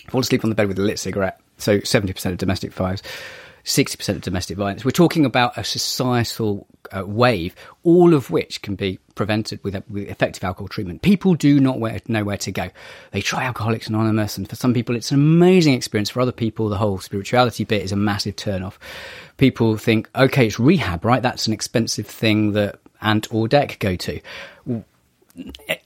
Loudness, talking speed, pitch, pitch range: -20 LUFS, 195 wpm, 110 Hz, 100-125 Hz